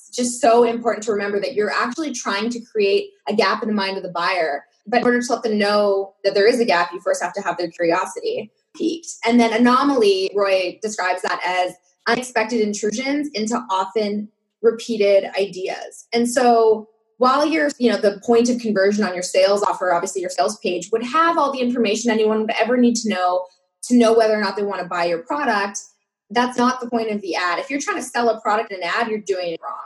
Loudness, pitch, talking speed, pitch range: -19 LUFS, 220 Hz, 225 wpm, 195-240 Hz